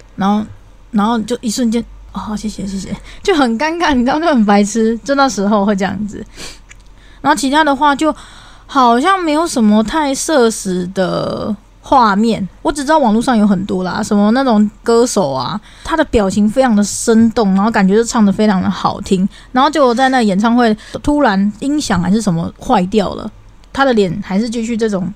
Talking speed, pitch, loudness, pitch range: 285 characters per minute, 225 Hz, -14 LUFS, 200-260 Hz